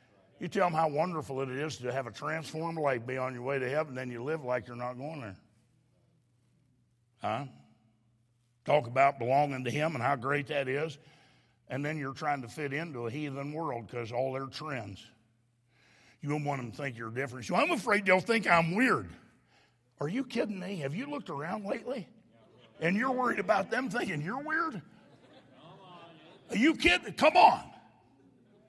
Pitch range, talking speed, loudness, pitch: 125-170 Hz, 185 wpm, -31 LUFS, 145 Hz